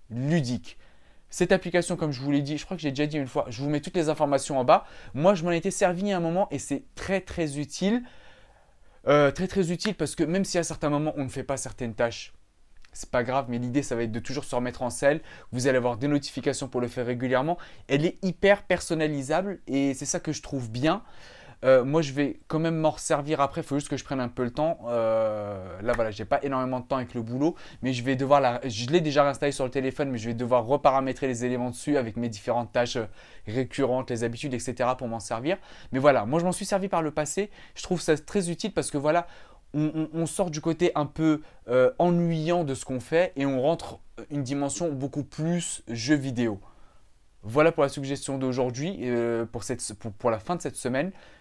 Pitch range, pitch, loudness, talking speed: 125-160 Hz, 140 Hz, -27 LUFS, 240 wpm